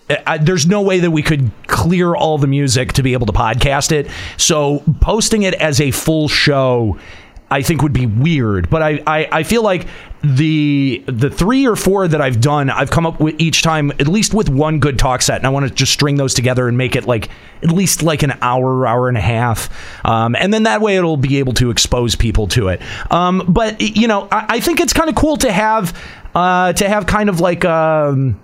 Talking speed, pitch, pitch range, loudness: 230 wpm, 150 Hz, 130-180 Hz, -14 LUFS